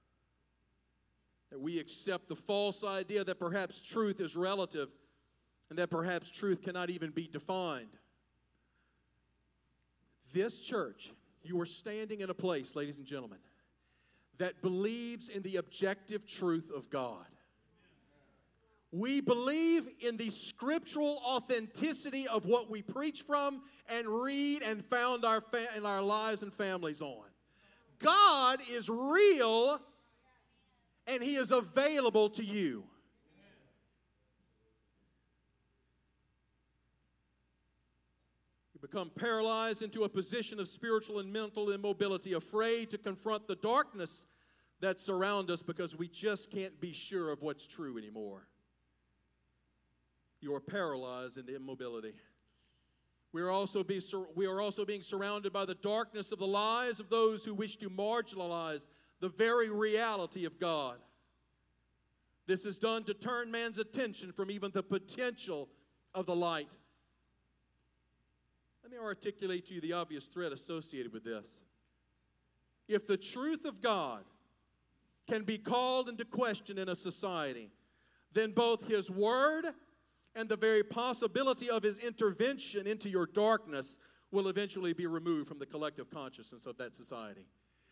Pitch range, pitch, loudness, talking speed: 135-220 Hz, 195 Hz, -35 LUFS, 130 wpm